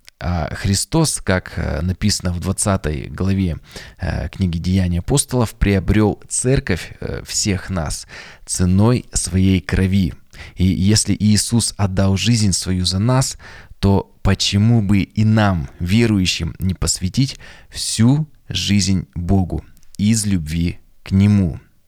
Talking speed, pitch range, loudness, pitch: 105 wpm, 90-105 Hz, -18 LUFS, 95 Hz